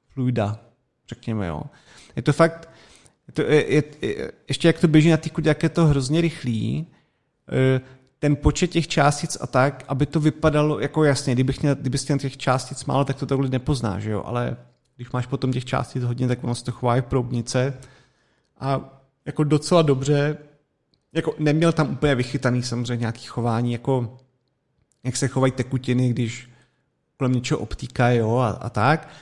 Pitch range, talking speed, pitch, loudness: 125-150 Hz, 170 wpm, 135 Hz, -22 LUFS